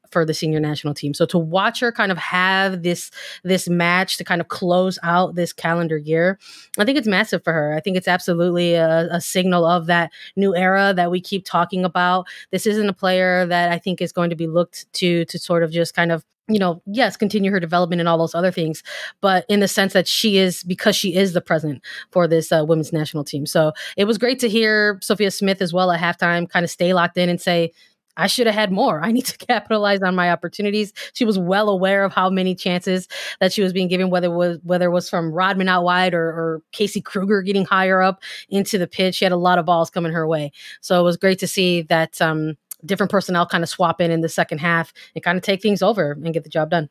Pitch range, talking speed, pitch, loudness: 170-195 Hz, 250 wpm, 180 Hz, -19 LUFS